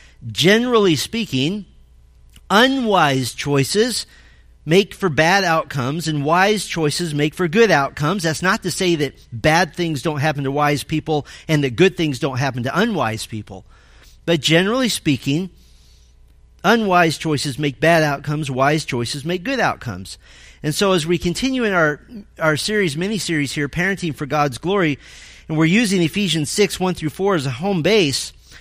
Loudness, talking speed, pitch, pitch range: -18 LUFS, 160 wpm, 155 Hz, 135-185 Hz